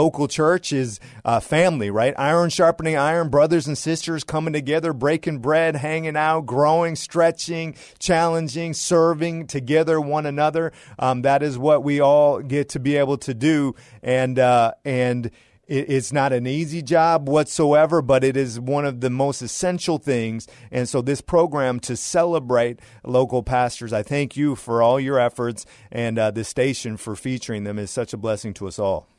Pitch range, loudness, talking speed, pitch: 125-160 Hz, -21 LUFS, 175 wpm, 140 Hz